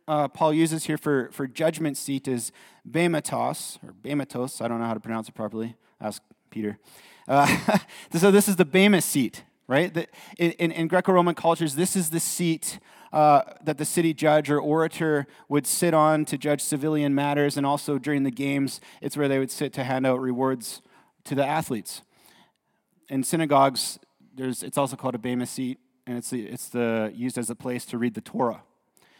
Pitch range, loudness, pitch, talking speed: 130-160 Hz, -25 LUFS, 145 Hz, 190 wpm